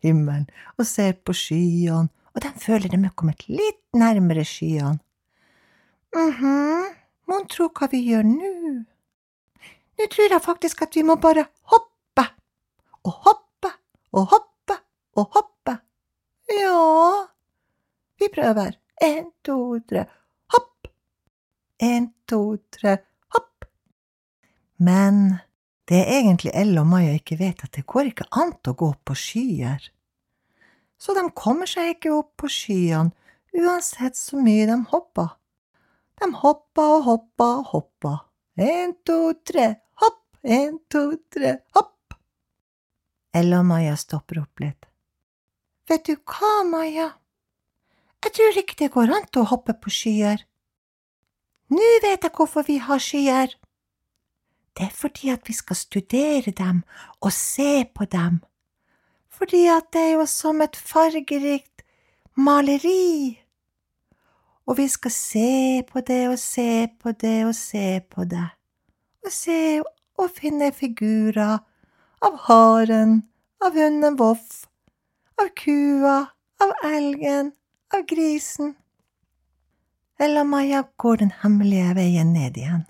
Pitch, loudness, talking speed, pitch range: 260 Hz, -21 LUFS, 130 wpm, 195-320 Hz